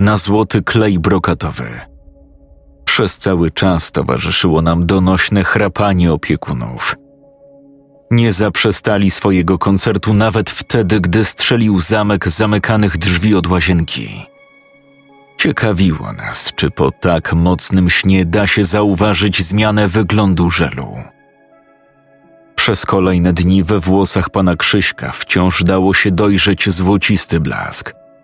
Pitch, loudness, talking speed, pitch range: 100 Hz, -13 LUFS, 110 wpm, 90-110 Hz